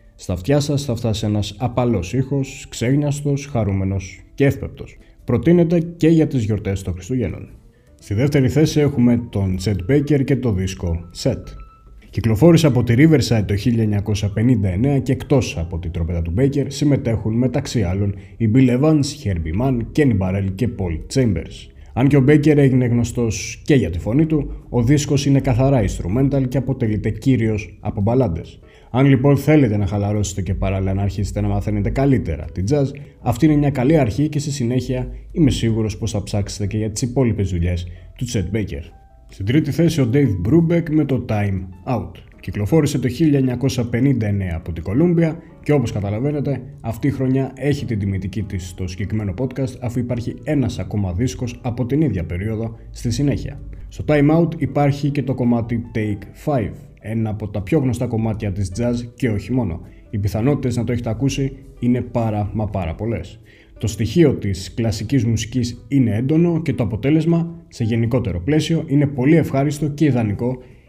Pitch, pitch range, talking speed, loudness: 120 Hz, 100-140 Hz, 170 wpm, -19 LUFS